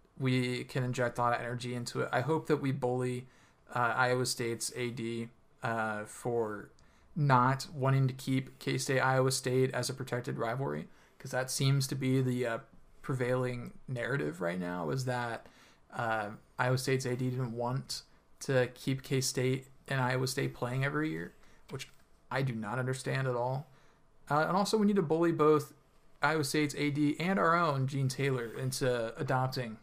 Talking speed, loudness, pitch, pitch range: 170 wpm, -33 LUFS, 130 Hz, 125-135 Hz